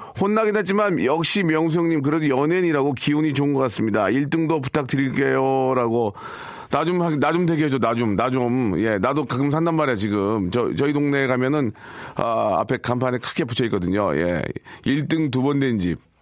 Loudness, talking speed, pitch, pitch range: -21 LUFS, 350 characters per minute, 140 Hz, 125-160 Hz